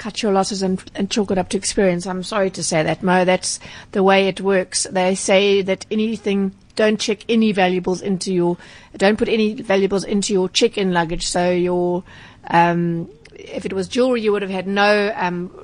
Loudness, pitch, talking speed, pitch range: -19 LUFS, 195 Hz, 200 wpm, 180-205 Hz